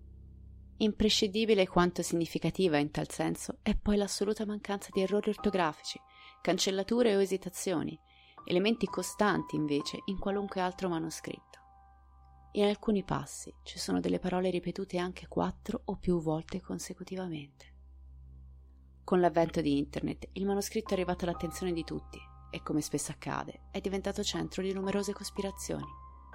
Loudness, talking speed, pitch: -33 LUFS, 130 wpm, 180 Hz